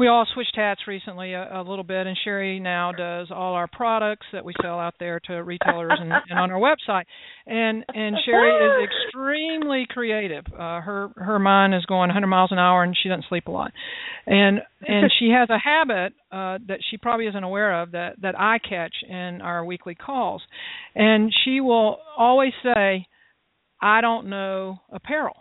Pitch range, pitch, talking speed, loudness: 185-235 Hz, 200 Hz, 190 wpm, -22 LUFS